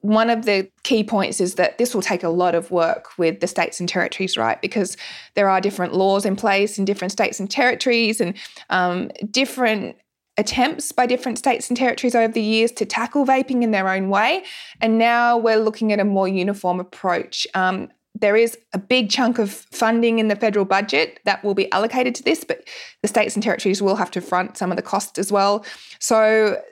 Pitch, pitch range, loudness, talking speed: 215 Hz, 195-235 Hz, -20 LUFS, 210 wpm